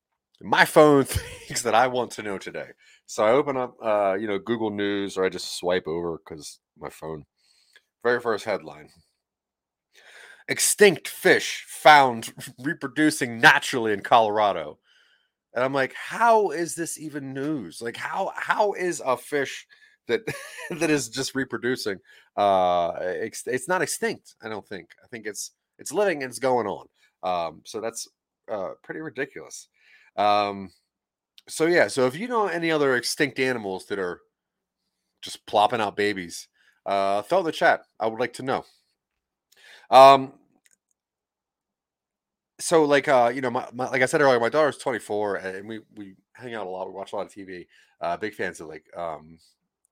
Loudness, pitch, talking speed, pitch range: -23 LUFS, 130 Hz, 165 wpm, 100-155 Hz